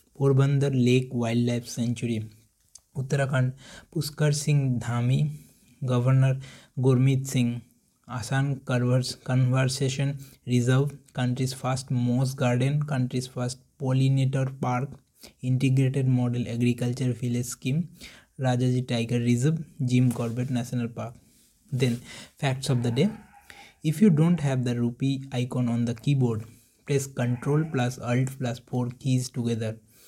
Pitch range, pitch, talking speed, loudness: 120-135 Hz, 130 Hz, 115 wpm, -26 LUFS